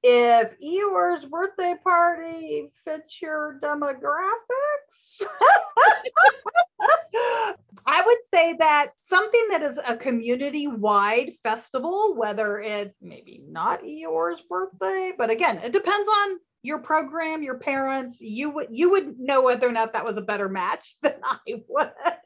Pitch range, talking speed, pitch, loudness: 230-355 Hz, 130 wpm, 295 Hz, -23 LUFS